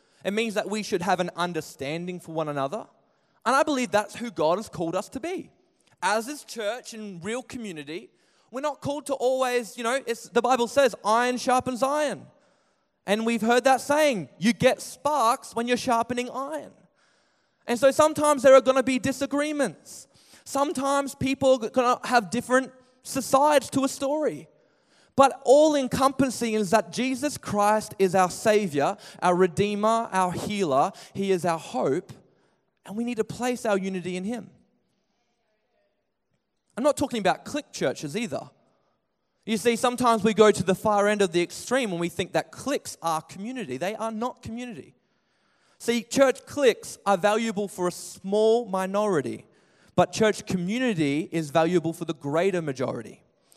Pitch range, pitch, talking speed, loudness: 190-260 Hz, 230 Hz, 165 wpm, -25 LUFS